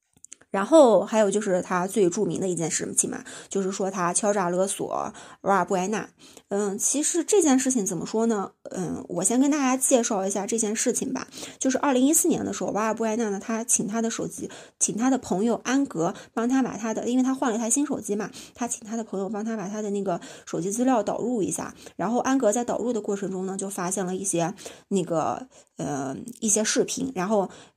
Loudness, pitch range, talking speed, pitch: -25 LUFS, 195-250 Hz, 320 characters per minute, 220 Hz